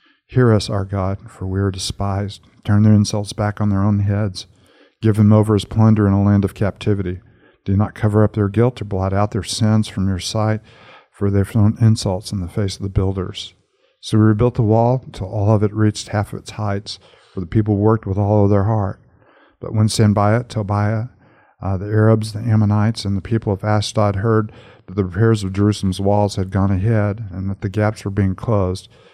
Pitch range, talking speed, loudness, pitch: 100-110 Hz, 215 wpm, -18 LUFS, 105 Hz